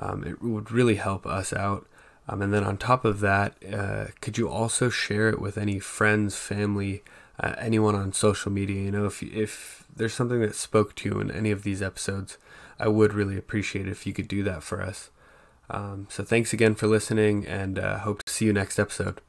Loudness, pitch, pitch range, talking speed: -27 LUFS, 105 Hz, 100-110 Hz, 220 wpm